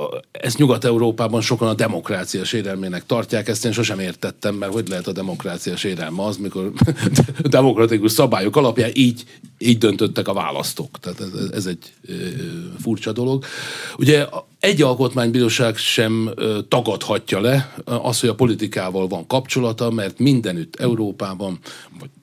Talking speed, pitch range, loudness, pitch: 135 wpm, 105-130 Hz, -19 LUFS, 115 Hz